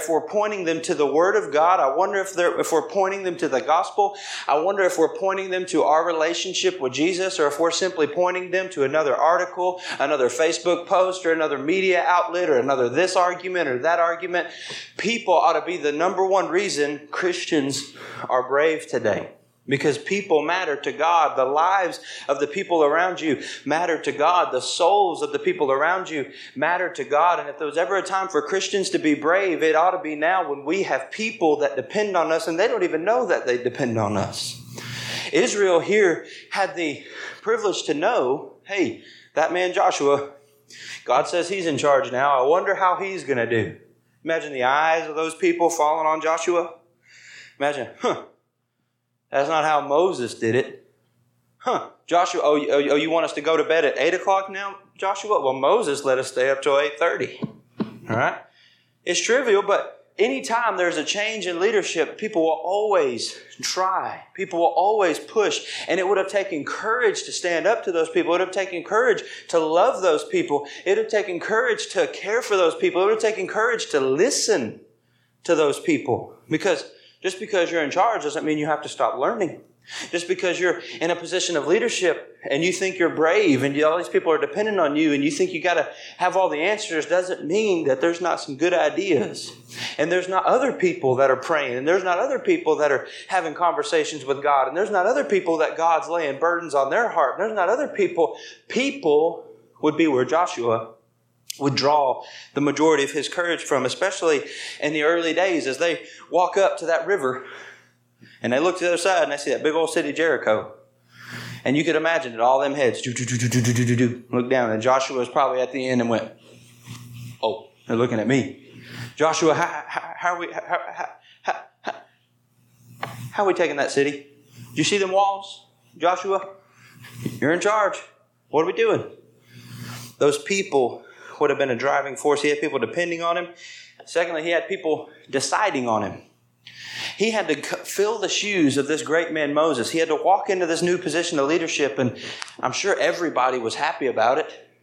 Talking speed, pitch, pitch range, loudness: 205 wpm, 175 Hz, 145-200 Hz, -22 LUFS